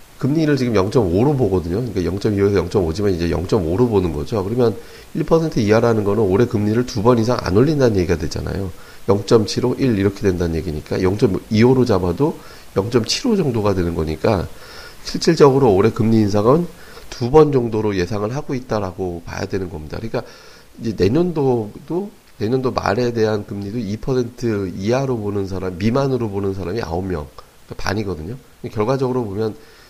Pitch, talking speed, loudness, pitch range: 110 Hz, 325 characters per minute, -18 LUFS, 95-125 Hz